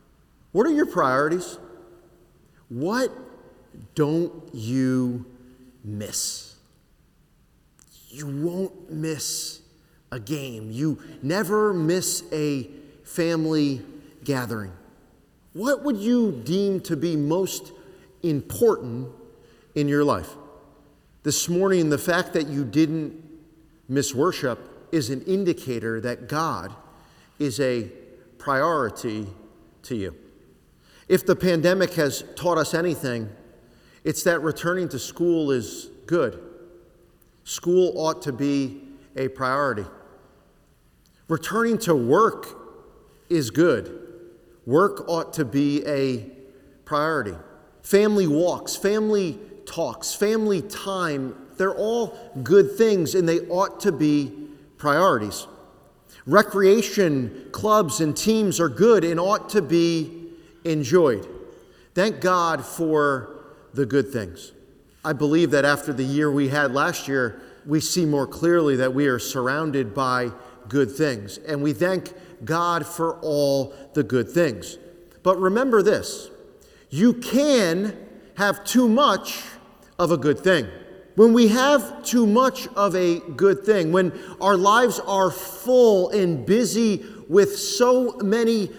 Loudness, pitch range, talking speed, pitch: -22 LUFS, 140-195 Hz, 120 wpm, 165 Hz